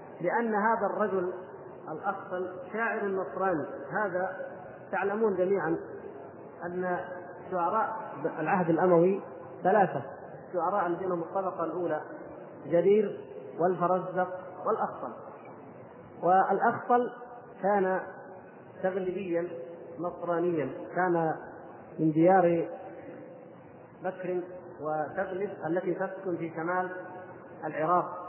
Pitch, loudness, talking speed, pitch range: 180 Hz, -30 LUFS, 75 wpm, 170-190 Hz